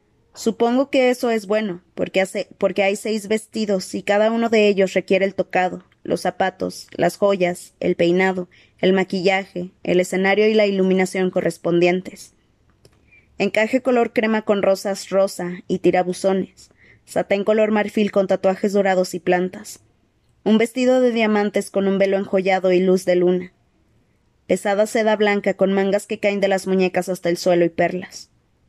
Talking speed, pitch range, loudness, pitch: 160 wpm, 180-210 Hz, -19 LUFS, 195 Hz